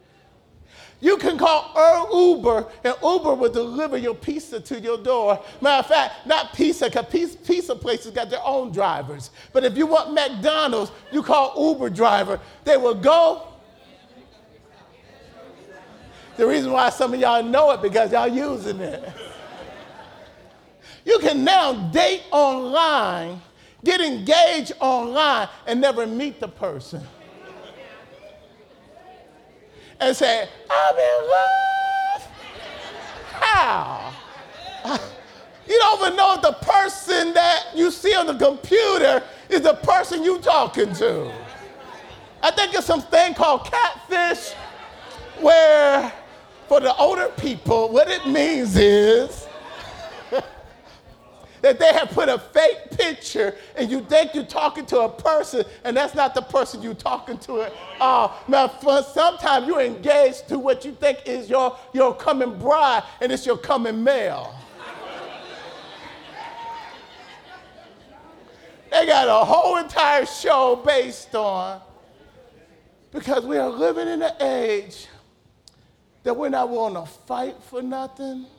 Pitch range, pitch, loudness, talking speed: 245-330 Hz, 280 Hz, -19 LUFS, 130 wpm